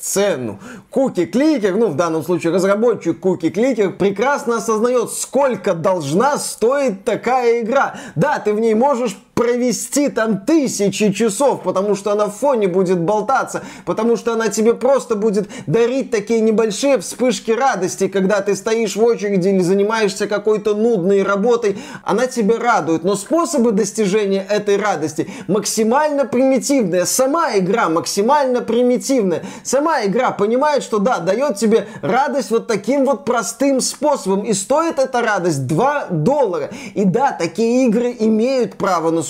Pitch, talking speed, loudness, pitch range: 225 Hz, 145 wpm, -17 LUFS, 195-250 Hz